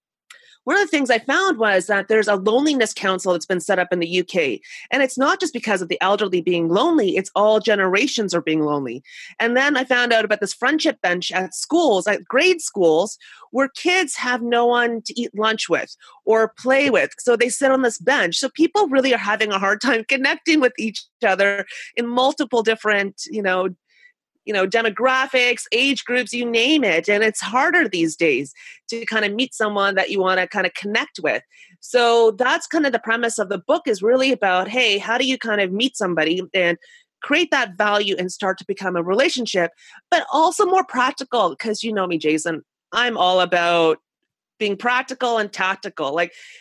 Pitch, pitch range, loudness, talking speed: 225 Hz, 190-265 Hz, -19 LUFS, 200 wpm